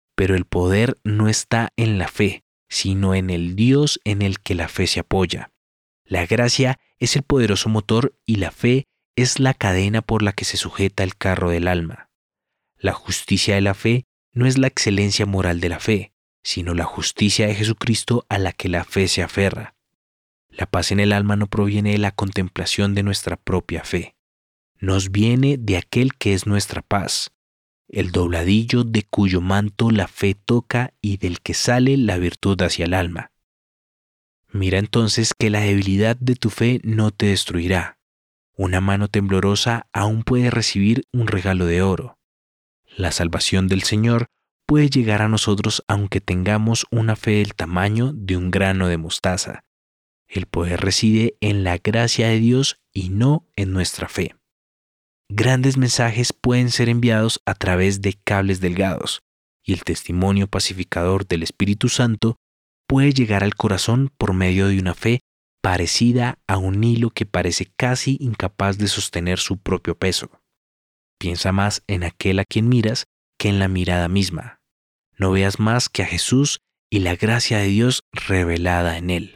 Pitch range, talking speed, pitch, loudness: 90-115 Hz, 170 wpm, 100 Hz, -20 LUFS